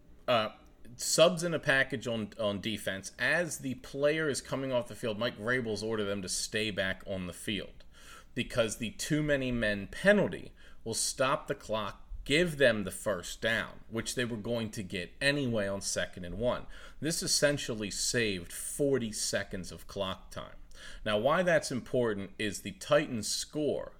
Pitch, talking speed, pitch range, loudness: 115 Hz, 170 wpm, 100-135 Hz, -32 LUFS